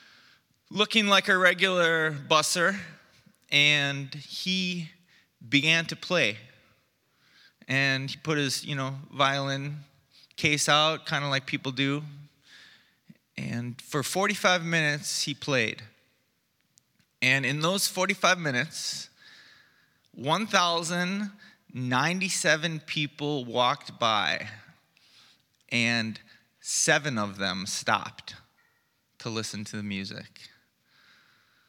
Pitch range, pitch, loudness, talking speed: 130-170 Hz, 145 Hz, -26 LUFS, 95 wpm